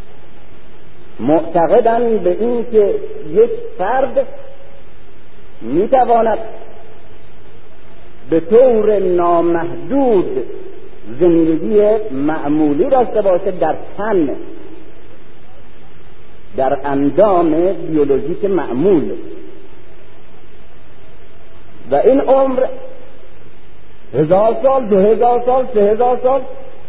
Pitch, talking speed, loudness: 235 Hz, 70 wpm, -14 LUFS